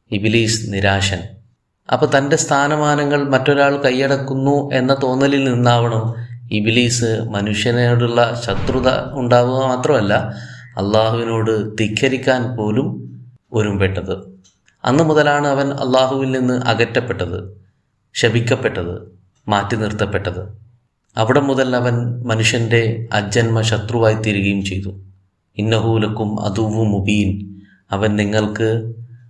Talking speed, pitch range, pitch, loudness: 80 wpm, 105-130 Hz, 115 Hz, -17 LUFS